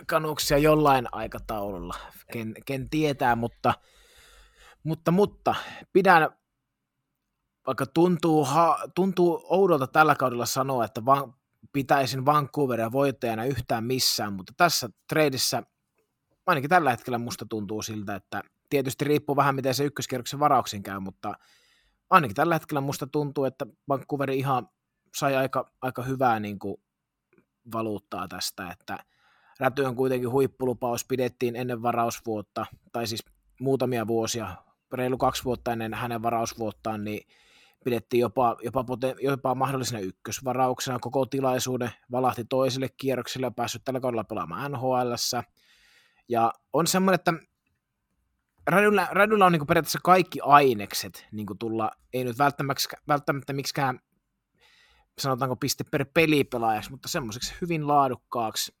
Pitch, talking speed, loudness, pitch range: 130 Hz, 120 wpm, -26 LUFS, 120-145 Hz